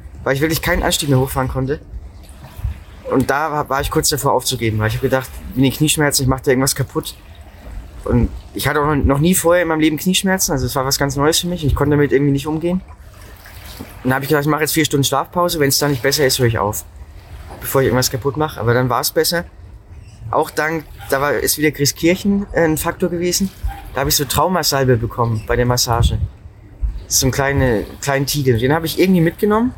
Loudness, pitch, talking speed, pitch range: -17 LUFS, 135 Hz, 225 wpm, 110-155 Hz